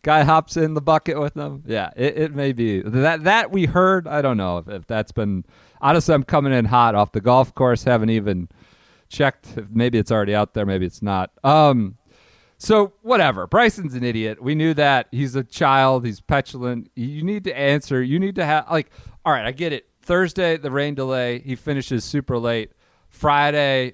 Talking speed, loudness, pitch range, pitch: 205 wpm, -20 LUFS, 115-155 Hz, 135 Hz